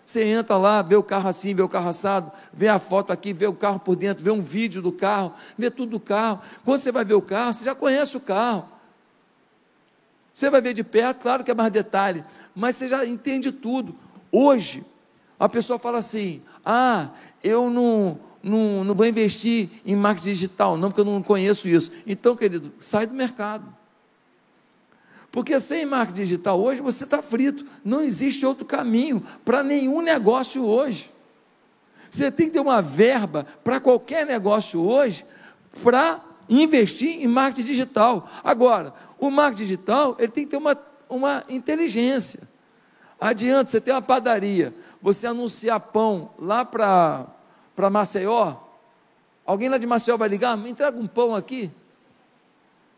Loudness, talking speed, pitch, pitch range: -22 LUFS, 165 wpm, 230 Hz, 200-260 Hz